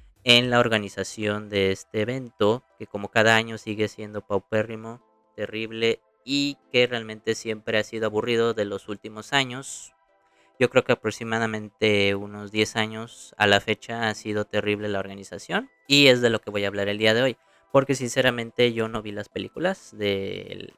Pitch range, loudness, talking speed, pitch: 105-115 Hz, -24 LUFS, 175 wpm, 110 Hz